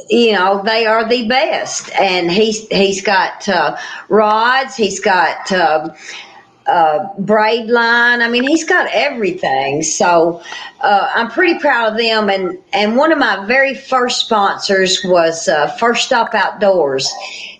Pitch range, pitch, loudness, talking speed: 190-235 Hz, 215 Hz, -13 LUFS, 145 wpm